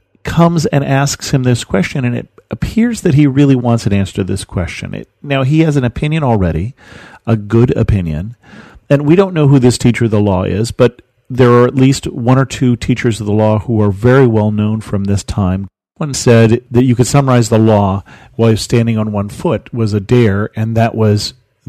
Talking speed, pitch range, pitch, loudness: 215 wpm, 105-135 Hz, 120 Hz, -12 LUFS